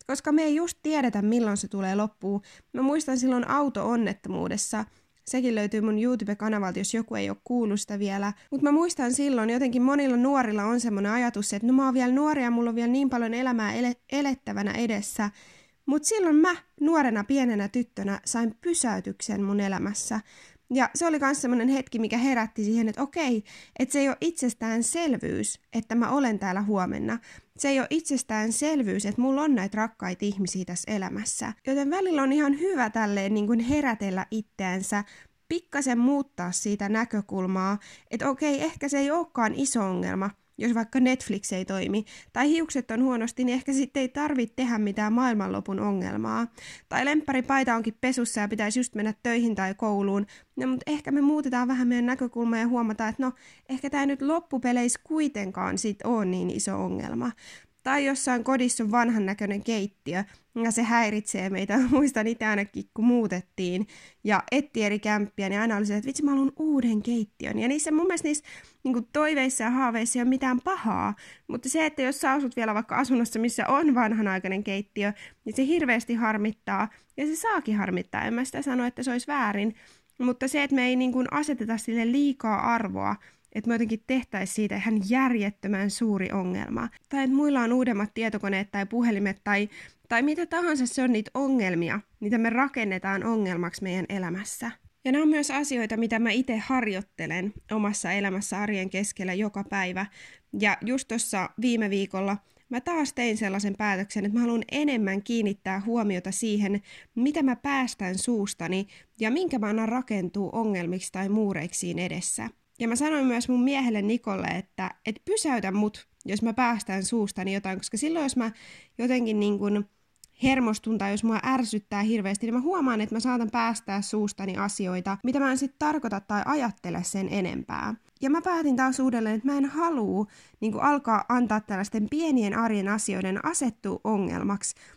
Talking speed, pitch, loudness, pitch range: 170 wpm, 230 Hz, -27 LUFS, 205-265 Hz